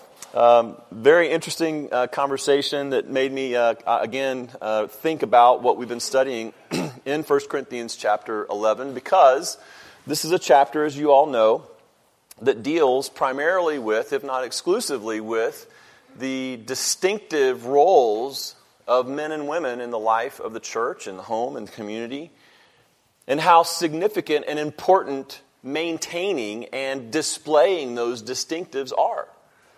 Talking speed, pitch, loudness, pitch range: 140 wpm, 135 Hz, -22 LUFS, 120-155 Hz